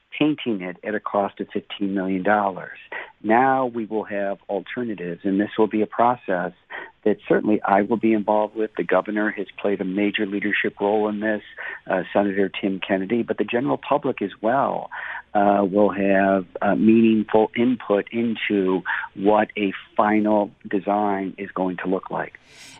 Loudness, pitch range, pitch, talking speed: -22 LUFS, 100-110 Hz, 105 Hz, 165 wpm